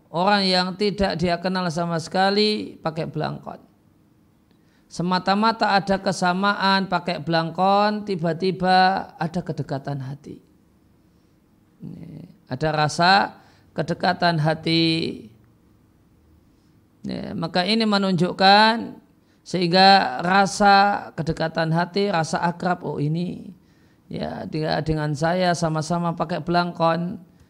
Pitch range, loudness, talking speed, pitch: 165-195 Hz, -21 LUFS, 85 wpm, 180 Hz